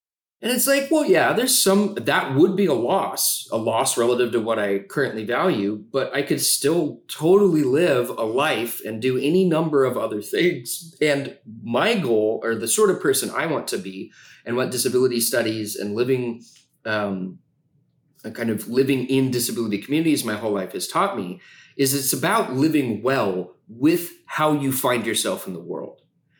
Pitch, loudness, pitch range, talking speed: 130 Hz, -21 LUFS, 110-160 Hz, 180 wpm